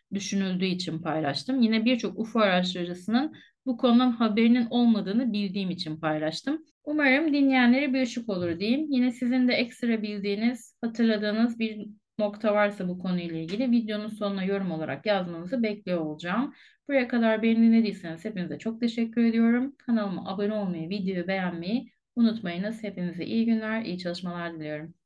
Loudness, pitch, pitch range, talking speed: -27 LUFS, 215 Hz, 180-240 Hz, 140 wpm